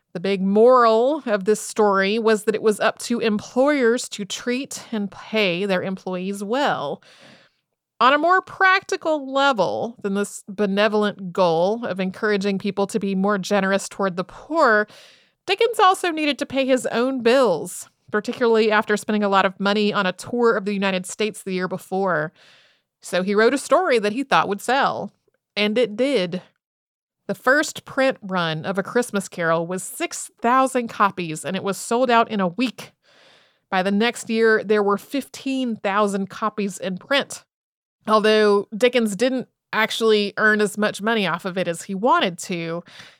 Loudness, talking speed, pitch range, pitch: -21 LUFS, 170 wpm, 195-245 Hz, 210 Hz